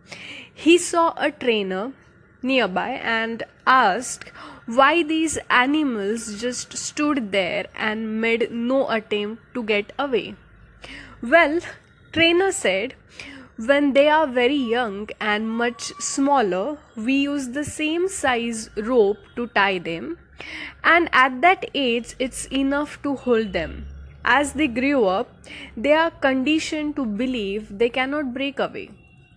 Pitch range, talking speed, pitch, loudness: 225-300 Hz, 125 wpm, 260 Hz, -21 LUFS